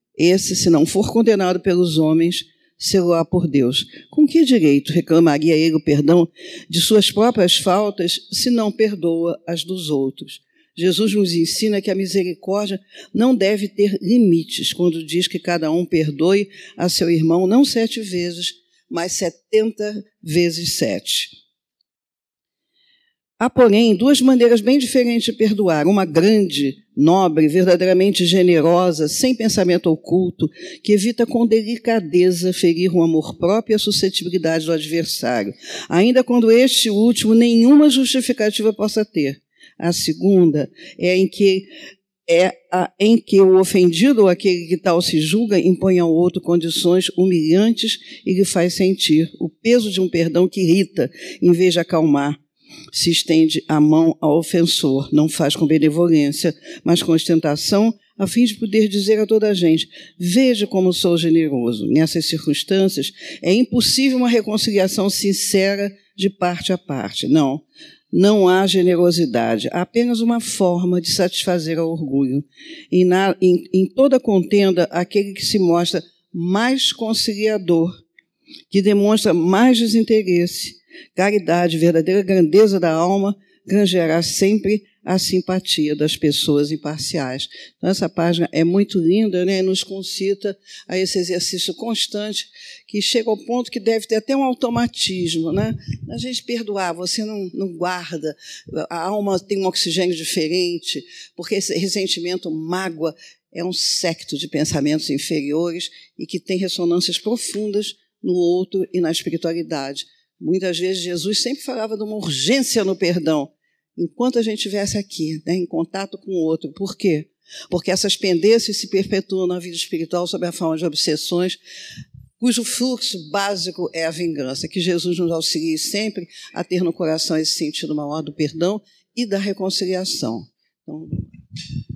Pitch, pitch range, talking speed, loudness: 185 Hz, 170-210 Hz, 145 wpm, -17 LUFS